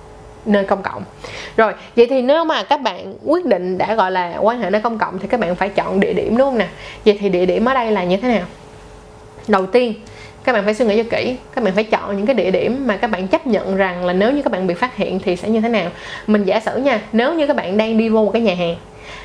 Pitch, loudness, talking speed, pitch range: 215 Hz, -17 LUFS, 285 wpm, 190-240 Hz